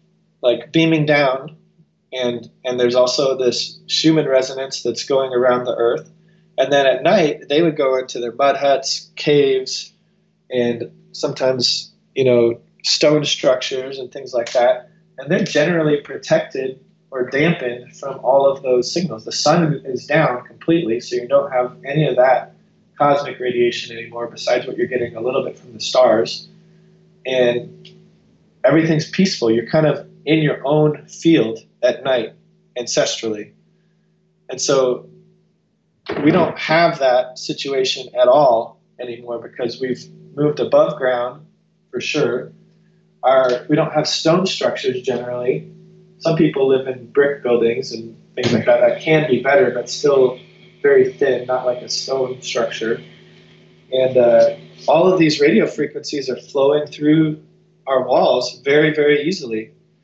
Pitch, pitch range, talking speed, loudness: 150 Hz, 125-175 Hz, 150 wpm, -17 LUFS